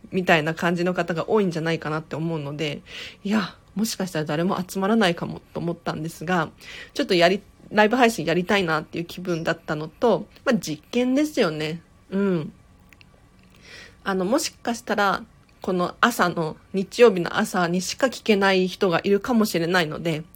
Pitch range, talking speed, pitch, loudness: 165-205 Hz, 360 characters per minute, 180 Hz, -23 LUFS